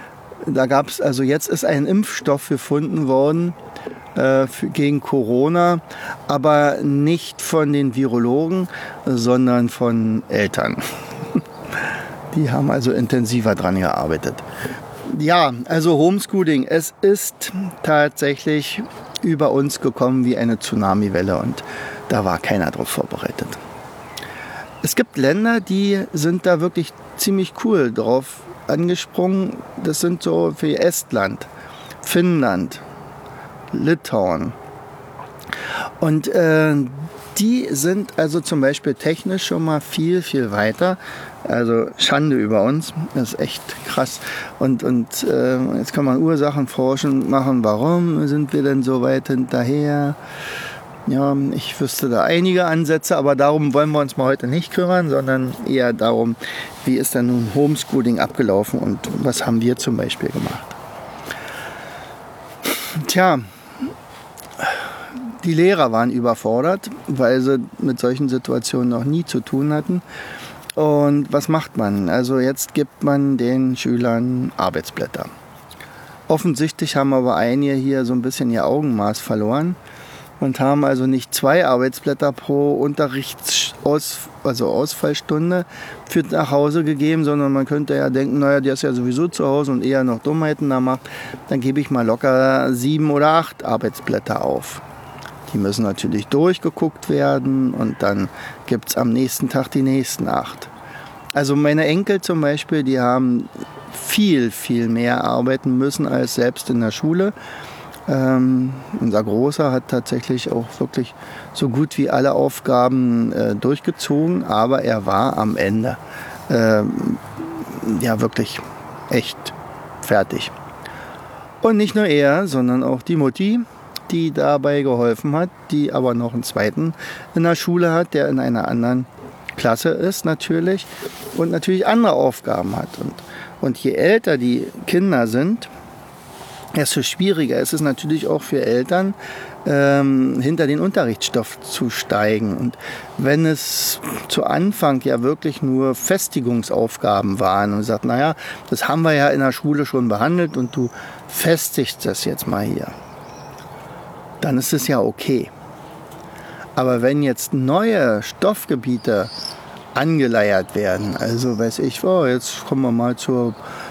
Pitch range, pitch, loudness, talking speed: 125-165 Hz, 140 Hz, -19 LUFS, 135 wpm